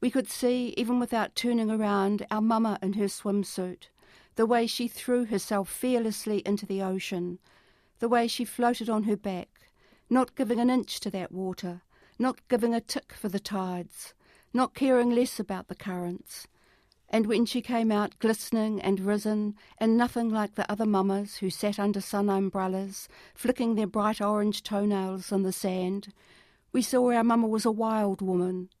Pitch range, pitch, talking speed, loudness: 195-235 Hz, 210 Hz, 175 wpm, -28 LUFS